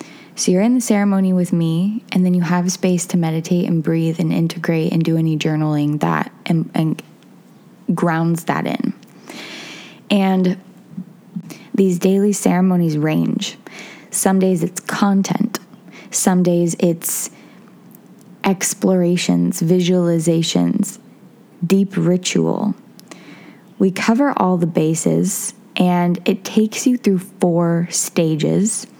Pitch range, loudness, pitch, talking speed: 170-200 Hz, -17 LUFS, 185 Hz, 115 wpm